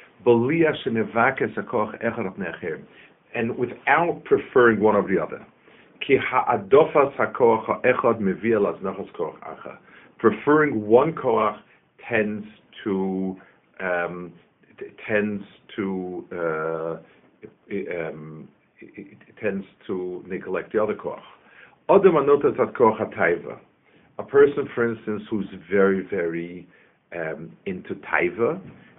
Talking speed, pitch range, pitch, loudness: 70 wpm, 90-120 Hz, 100 Hz, -23 LUFS